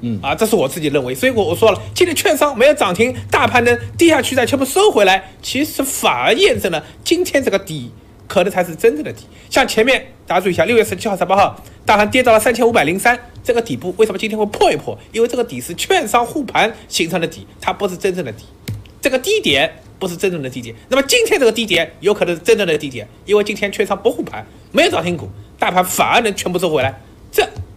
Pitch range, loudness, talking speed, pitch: 165-245 Hz, -15 LUFS, 370 characters per minute, 205 Hz